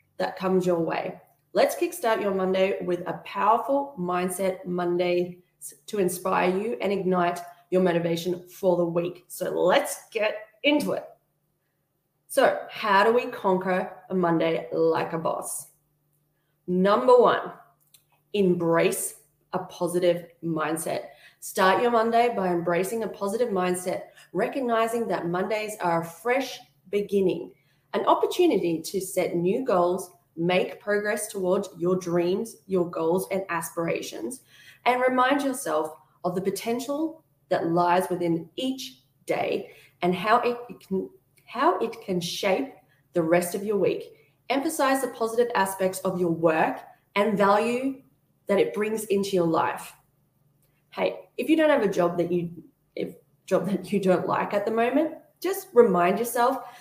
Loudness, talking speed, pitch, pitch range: -25 LUFS, 140 wpm, 185 Hz, 175-225 Hz